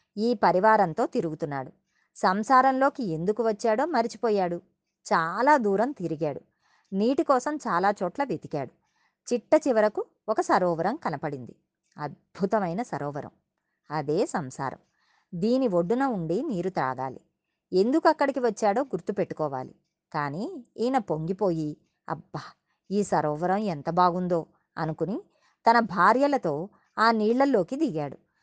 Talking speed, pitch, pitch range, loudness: 100 wpm, 205 Hz, 170-245 Hz, -26 LUFS